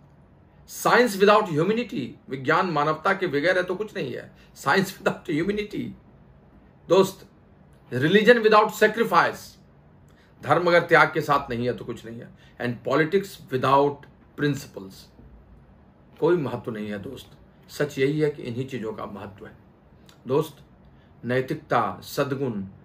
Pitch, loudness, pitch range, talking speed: 145 Hz, -23 LUFS, 120-185 Hz, 135 wpm